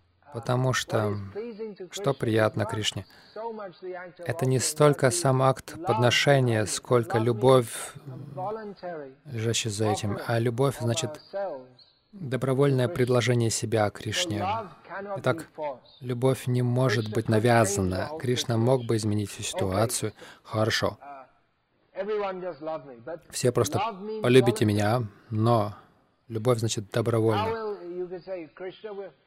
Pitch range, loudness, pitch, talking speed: 115-155 Hz, -26 LUFS, 125 Hz, 90 wpm